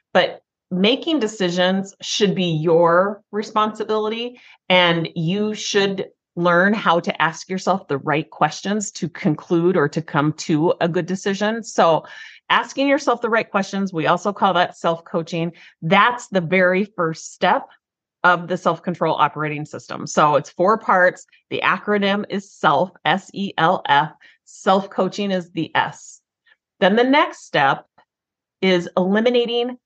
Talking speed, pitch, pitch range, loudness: 145 wpm, 185 Hz, 170-210 Hz, -19 LUFS